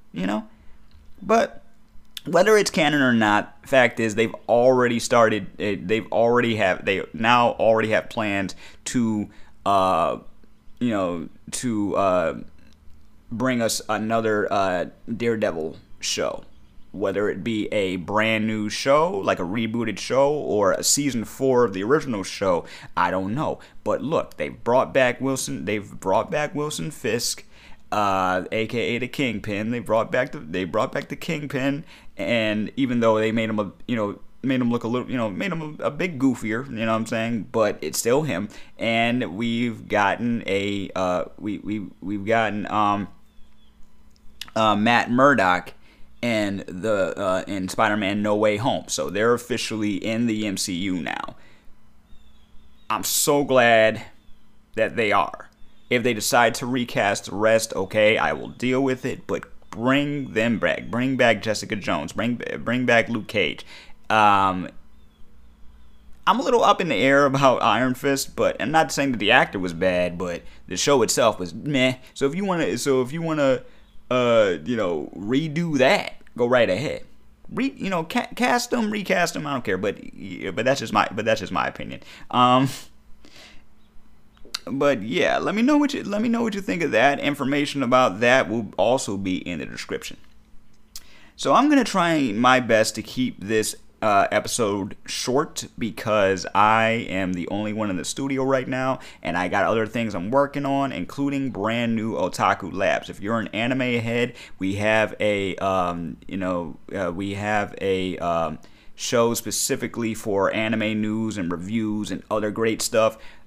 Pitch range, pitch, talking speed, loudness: 105-130 Hz, 115 Hz, 170 wpm, -22 LUFS